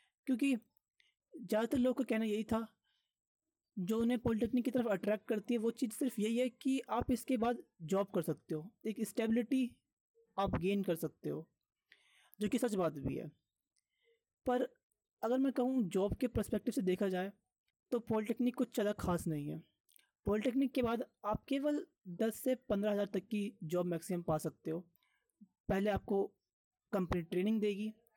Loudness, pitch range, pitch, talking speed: -37 LUFS, 195-250 Hz, 220 Hz, 170 wpm